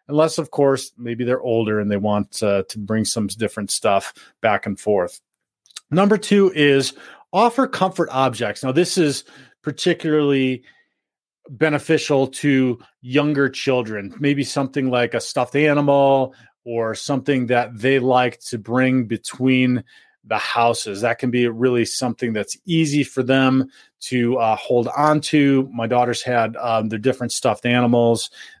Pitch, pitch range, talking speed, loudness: 130 Hz, 115-145 Hz, 145 wpm, -19 LUFS